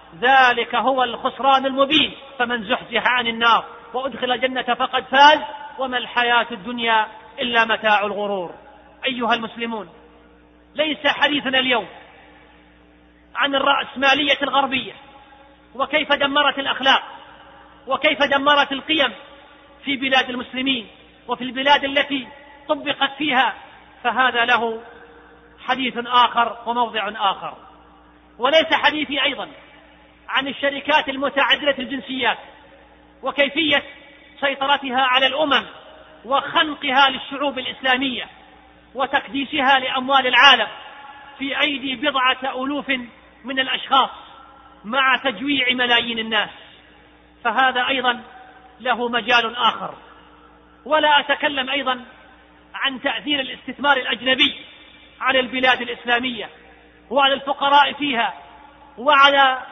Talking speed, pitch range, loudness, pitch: 90 wpm, 240-280 Hz, -18 LUFS, 265 Hz